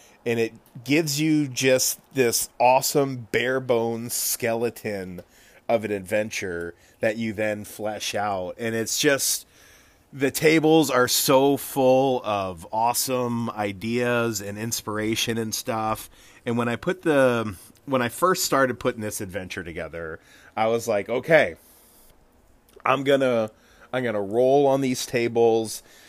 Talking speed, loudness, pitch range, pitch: 135 wpm, -23 LUFS, 110-130 Hz, 120 Hz